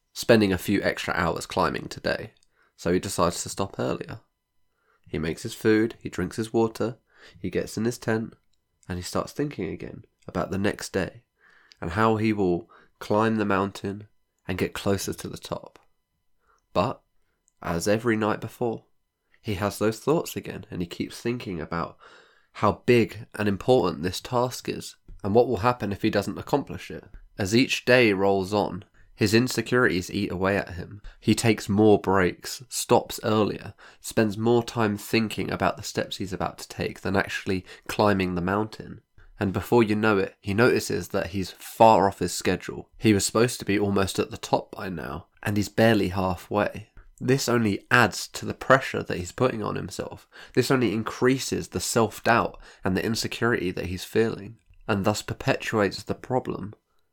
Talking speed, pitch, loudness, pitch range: 175 wpm, 105 Hz, -25 LUFS, 95-115 Hz